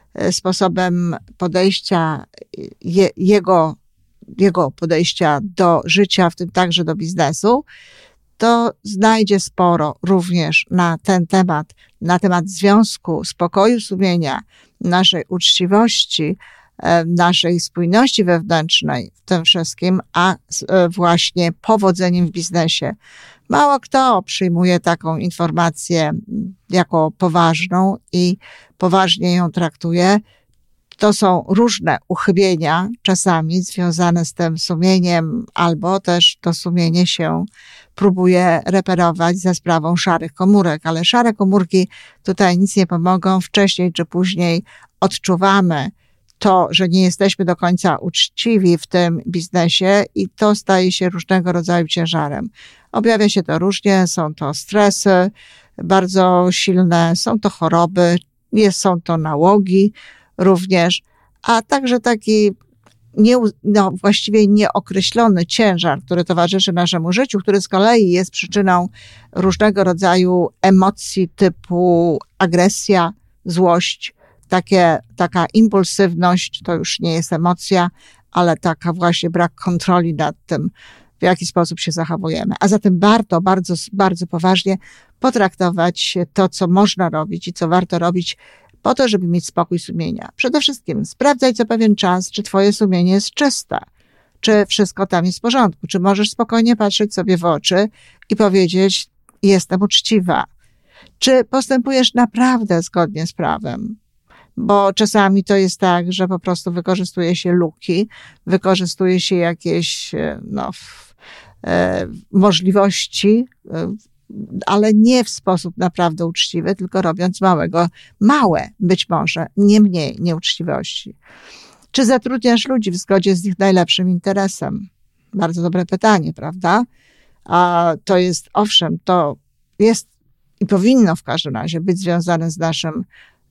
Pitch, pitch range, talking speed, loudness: 185 Hz, 175-200 Hz, 120 wpm, -15 LUFS